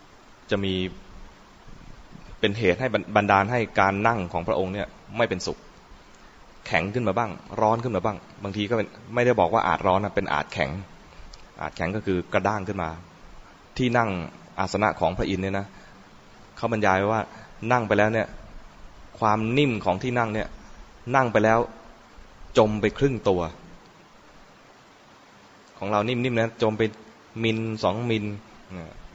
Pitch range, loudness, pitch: 95-115 Hz, -25 LUFS, 105 Hz